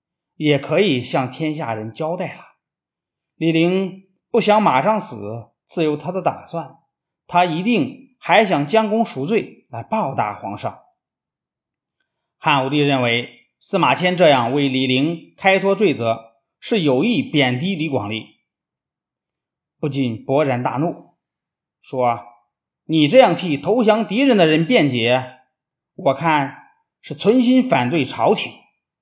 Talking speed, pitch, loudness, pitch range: 185 characters per minute, 160 Hz, -18 LUFS, 130-190 Hz